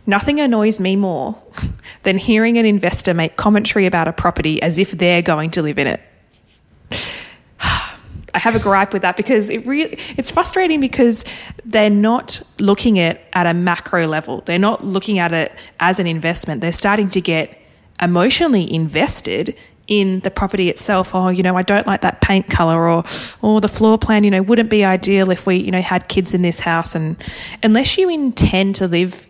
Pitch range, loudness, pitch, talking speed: 175-215 Hz, -16 LUFS, 190 Hz, 195 wpm